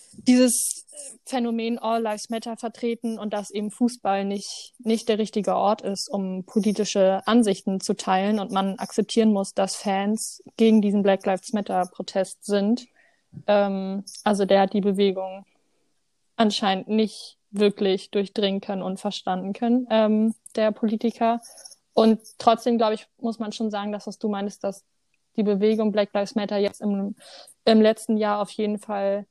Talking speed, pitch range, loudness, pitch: 160 wpm, 195-225 Hz, -24 LUFS, 210 Hz